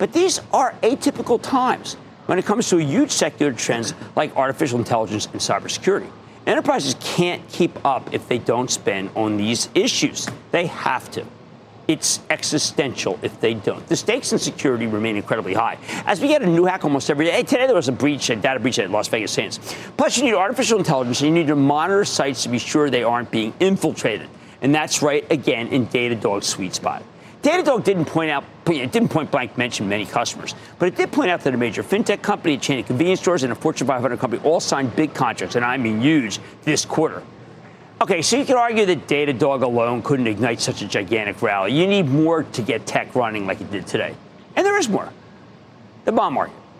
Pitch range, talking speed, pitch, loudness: 125-195 Hz, 210 wpm, 155 Hz, -20 LUFS